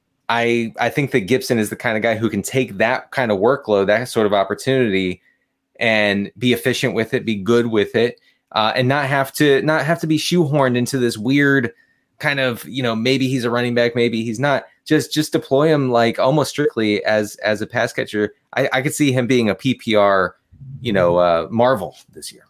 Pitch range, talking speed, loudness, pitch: 110-135 Hz, 215 wpm, -18 LUFS, 125 Hz